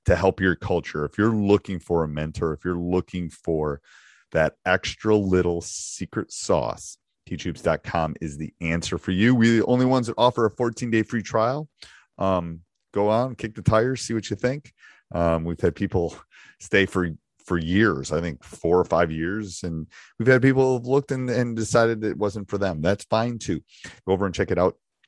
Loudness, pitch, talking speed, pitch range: -24 LUFS, 100 Hz, 195 wpm, 85-115 Hz